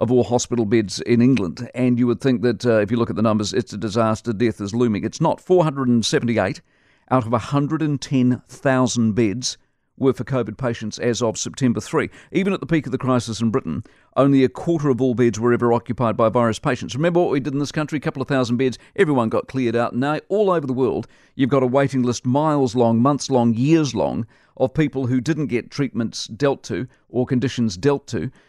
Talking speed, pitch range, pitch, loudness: 220 wpm, 120-140 Hz, 125 Hz, -20 LUFS